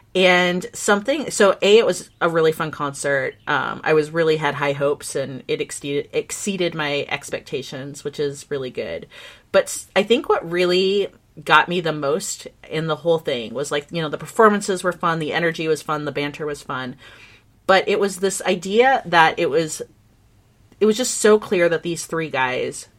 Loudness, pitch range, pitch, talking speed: -20 LUFS, 145-190 Hz, 160 Hz, 190 wpm